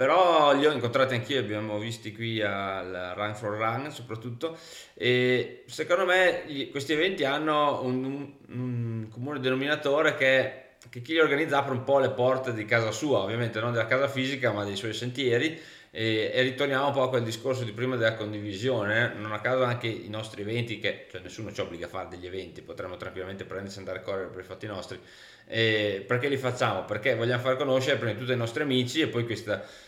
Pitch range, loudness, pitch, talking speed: 110-135 Hz, -27 LUFS, 125 Hz, 210 wpm